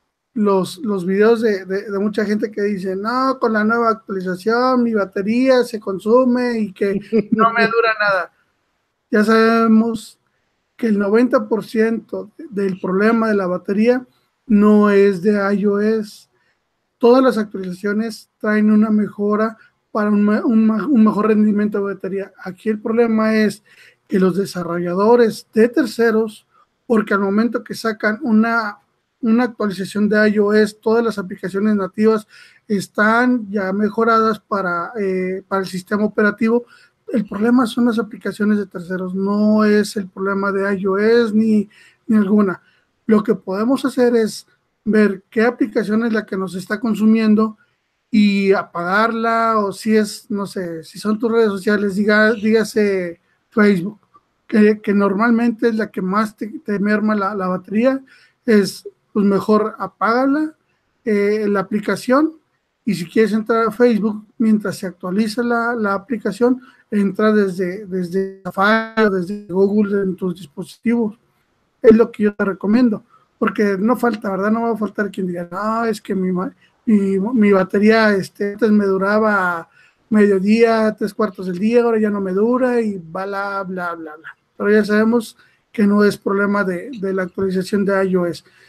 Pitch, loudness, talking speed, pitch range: 215 Hz, -17 LUFS, 155 wpm, 195-225 Hz